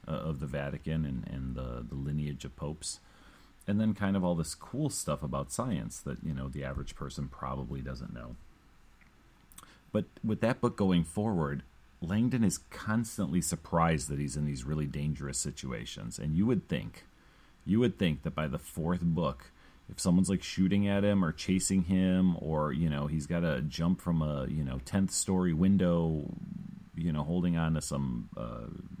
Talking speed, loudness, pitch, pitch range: 185 wpm, -32 LUFS, 85 Hz, 75-95 Hz